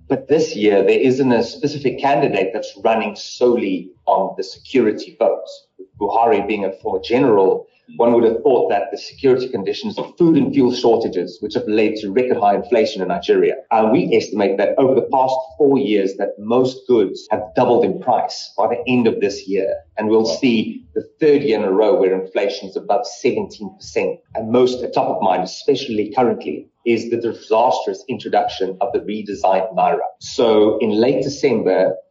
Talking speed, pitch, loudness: 185 wpm, 130 Hz, -17 LUFS